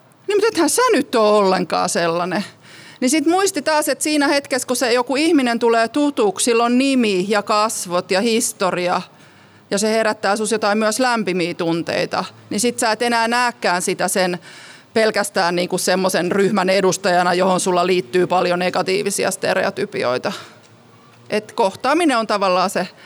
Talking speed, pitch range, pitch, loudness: 155 wpm, 180-245 Hz, 205 Hz, -18 LUFS